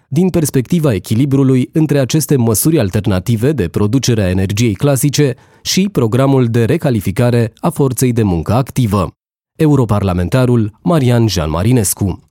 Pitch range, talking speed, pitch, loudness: 110-140 Hz, 120 wpm, 125 Hz, -13 LUFS